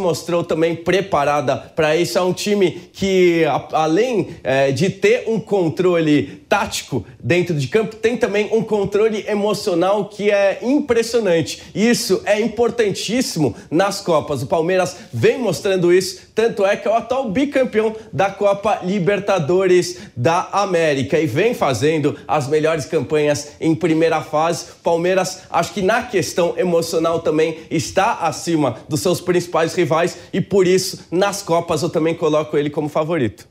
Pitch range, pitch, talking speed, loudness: 160-200 Hz, 175 Hz, 150 wpm, -18 LUFS